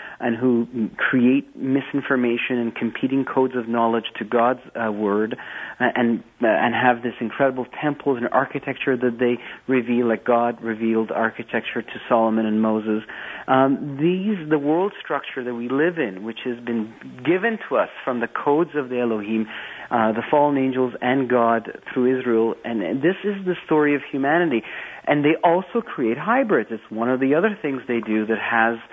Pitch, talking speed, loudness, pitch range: 125 Hz, 180 wpm, -22 LUFS, 115-140 Hz